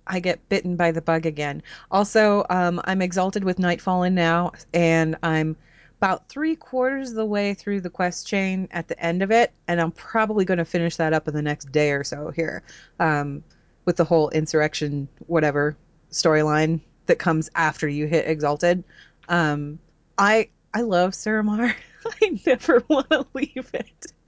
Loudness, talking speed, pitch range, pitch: -23 LUFS, 175 wpm, 160-200 Hz, 170 Hz